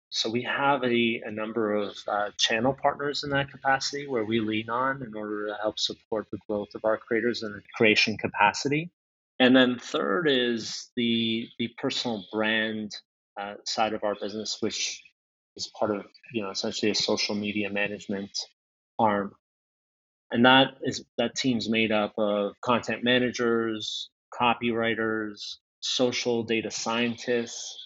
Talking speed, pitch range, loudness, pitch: 150 wpm, 105-125 Hz, -27 LUFS, 115 Hz